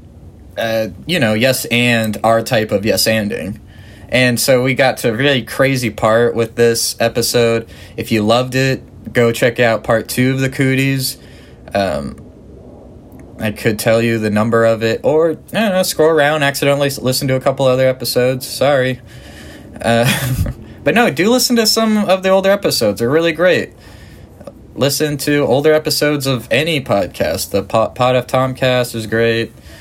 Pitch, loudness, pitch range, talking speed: 120 Hz, -14 LUFS, 110-135 Hz, 165 wpm